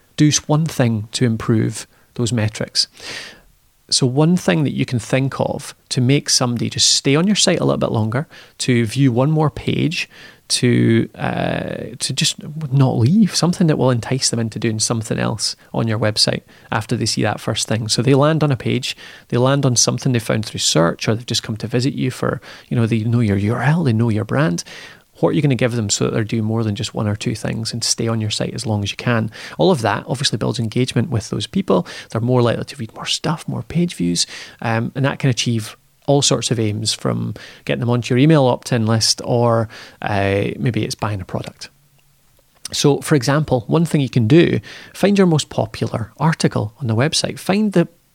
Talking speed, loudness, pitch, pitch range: 220 wpm, -18 LUFS, 125 Hz, 115-145 Hz